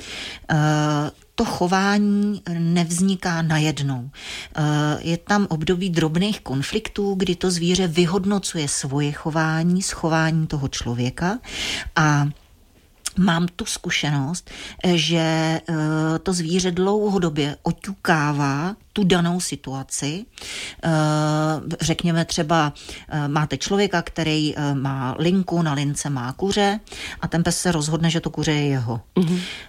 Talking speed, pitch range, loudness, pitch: 105 wpm, 150-185 Hz, -22 LUFS, 165 Hz